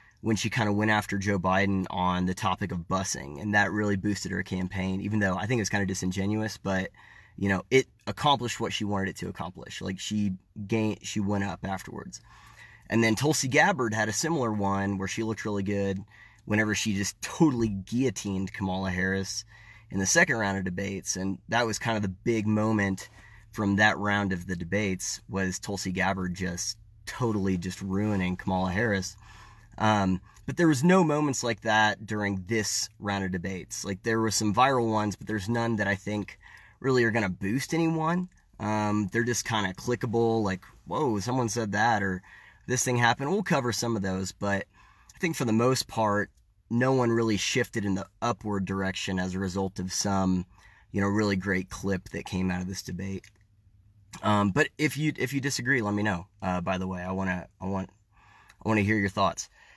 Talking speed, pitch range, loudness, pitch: 200 wpm, 95-115 Hz, -28 LUFS, 105 Hz